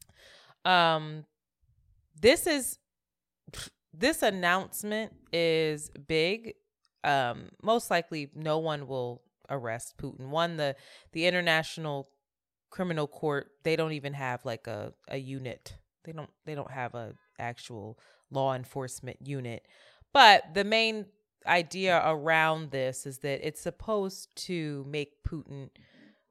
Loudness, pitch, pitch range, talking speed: -29 LUFS, 155 Hz, 135-175 Hz, 120 wpm